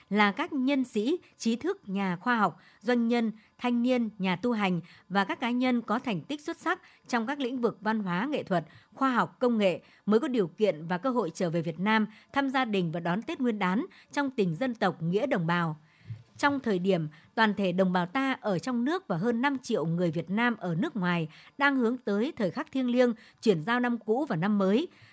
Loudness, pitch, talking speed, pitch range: -29 LUFS, 220 Hz, 235 wpm, 185-250 Hz